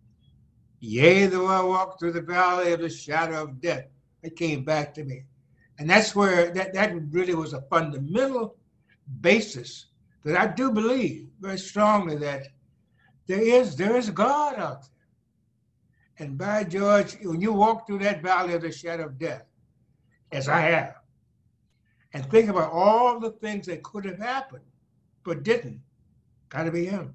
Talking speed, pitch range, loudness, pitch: 160 wpm, 145-205 Hz, -24 LUFS, 170 Hz